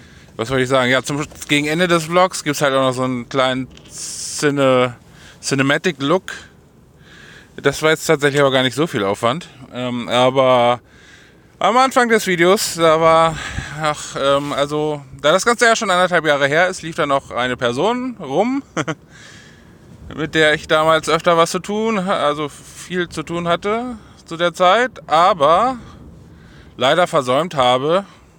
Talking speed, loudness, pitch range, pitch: 160 wpm, -17 LUFS, 135-180 Hz, 155 Hz